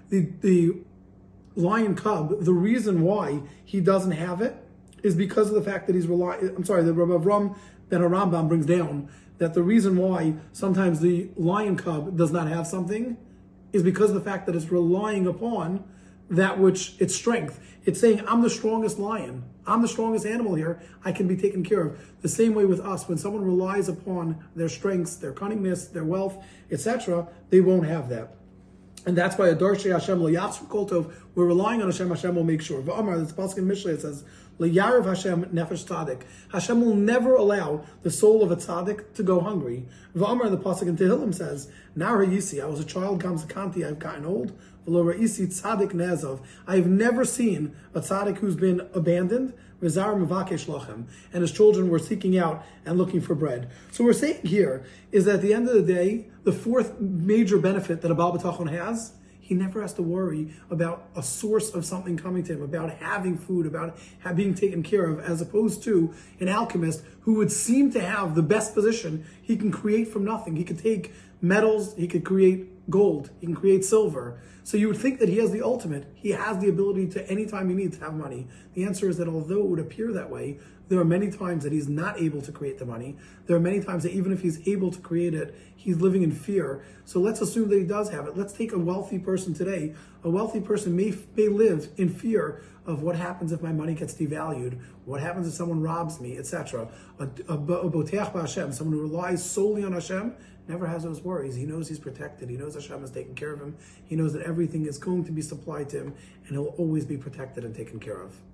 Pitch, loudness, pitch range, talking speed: 180 Hz, -25 LUFS, 165-200 Hz, 205 wpm